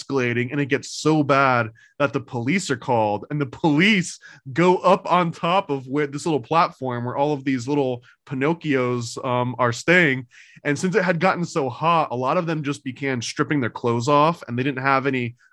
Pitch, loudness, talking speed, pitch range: 140 Hz, -21 LUFS, 210 wpm, 125-160 Hz